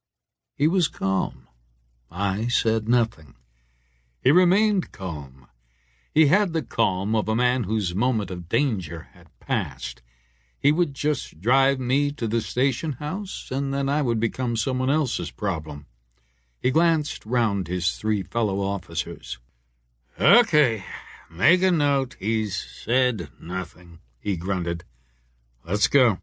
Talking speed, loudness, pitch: 130 wpm, -24 LUFS, 105 Hz